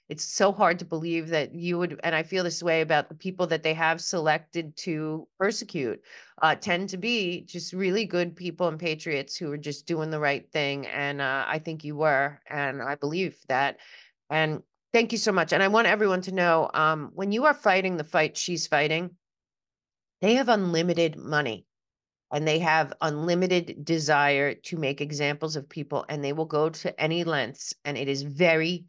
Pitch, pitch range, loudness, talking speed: 160 Hz, 150-180 Hz, -26 LUFS, 195 wpm